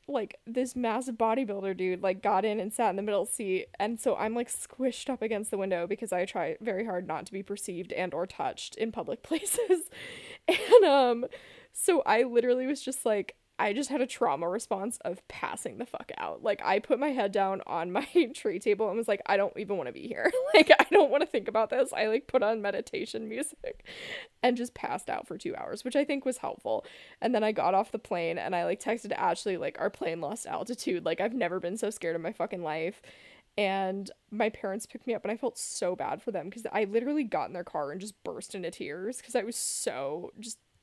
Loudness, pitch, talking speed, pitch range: -30 LUFS, 230 Hz, 235 wpm, 200-275 Hz